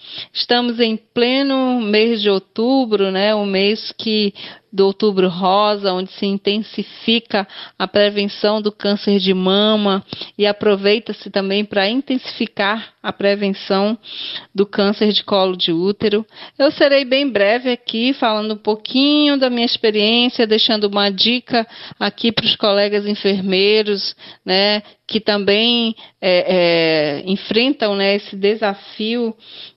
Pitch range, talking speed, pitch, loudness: 200-230 Hz, 130 wpm, 210 Hz, -16 LUFS